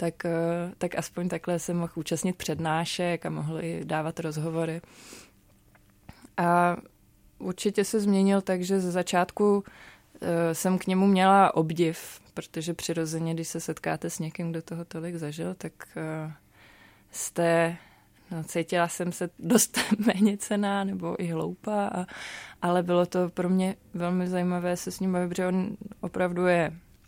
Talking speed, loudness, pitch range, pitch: 140 wpm, -28 LUFS, 165-185 Hz, 175 Hz